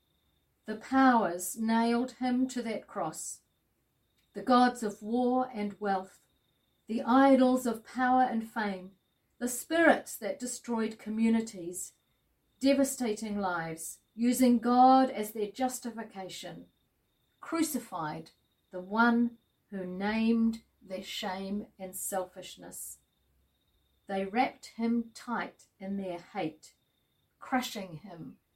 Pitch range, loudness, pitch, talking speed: 190-245 Hz, -30 LUFS, 225 Hz, 105 wpm